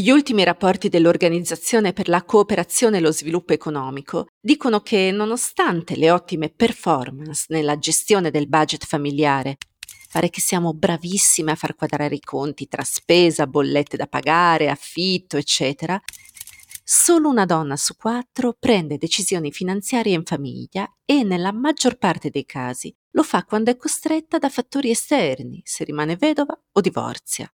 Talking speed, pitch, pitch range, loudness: 145 wpm, 175 Hz, 155-225 Hz, -20 LUFS